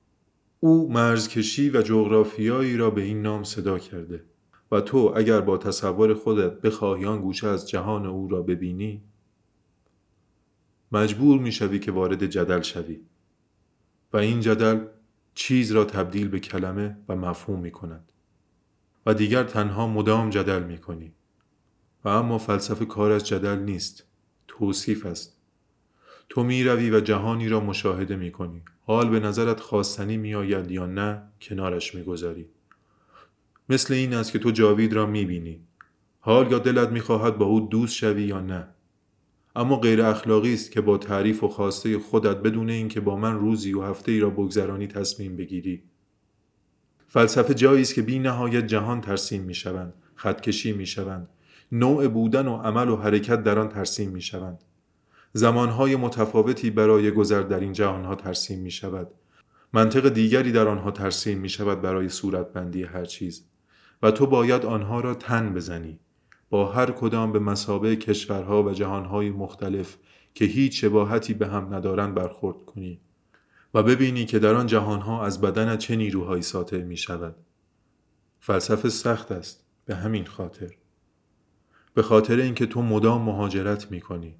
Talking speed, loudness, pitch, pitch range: 155 wpm, -24 LUFS, 105 Hz, 95-110 Hz